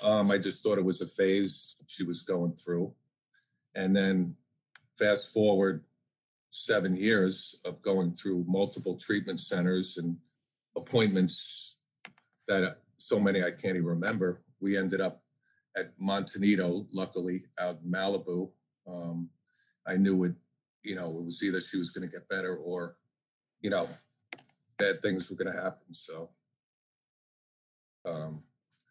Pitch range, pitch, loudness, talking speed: 85-95 Hz, 95 Hz, -31 LUFS, 140 wpm